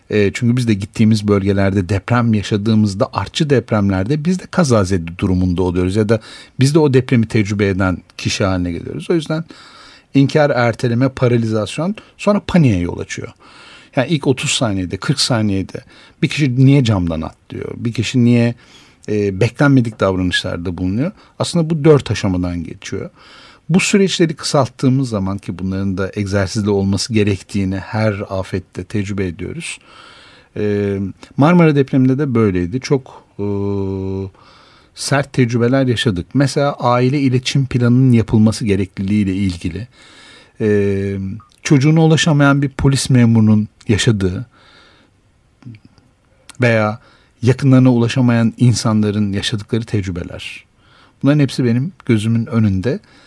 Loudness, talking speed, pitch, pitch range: -16 LUFS, 120 wpm, 115 Hz, 100-135 Hz